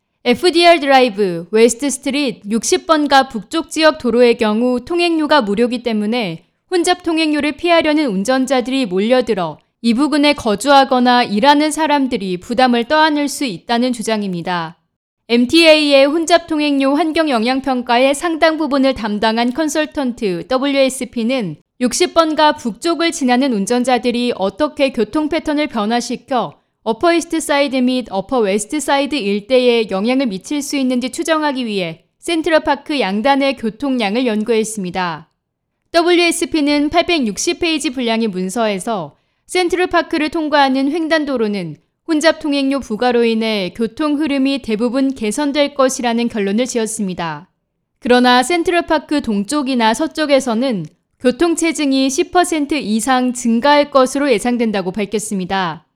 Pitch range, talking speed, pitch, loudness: 225-300 Hz, 315 characters per minute, 260 Hz, -15 LUFS